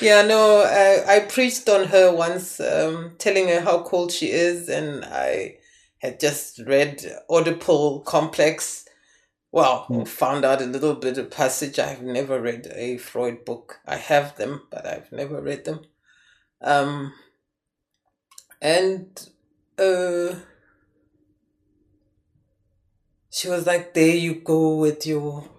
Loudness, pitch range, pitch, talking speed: -21 LUFS, 135-180 Hz, 160 Hz, 130 wpm